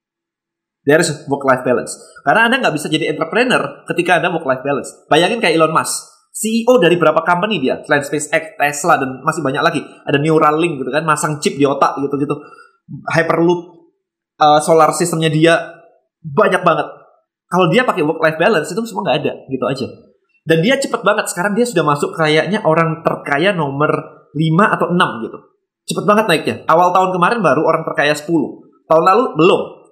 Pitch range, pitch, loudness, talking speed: 155-205 Hz, 165 Hz, -15 LUFS, 175 wpm